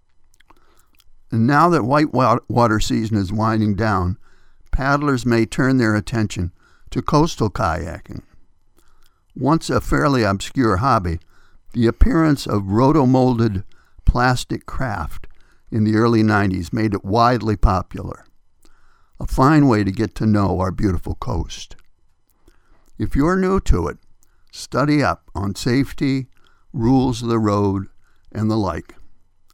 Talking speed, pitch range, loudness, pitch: 125 wpm, 95-130 Hz, -19 LUFS, 110 Hz